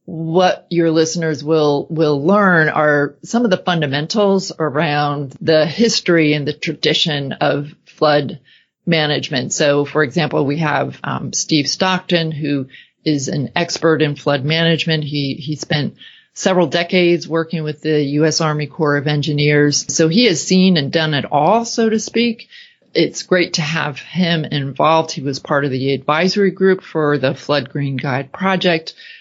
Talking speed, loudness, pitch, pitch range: 160 wpm, -16 LUFS, 155 Hz, 145-175 Hz